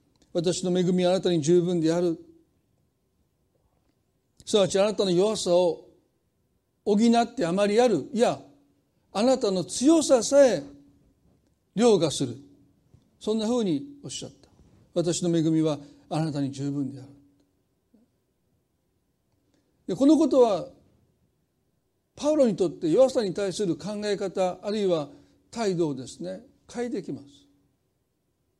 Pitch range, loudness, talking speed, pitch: 150-225 Hz, -25 LUFS, 230 characters per minute, 185 Hz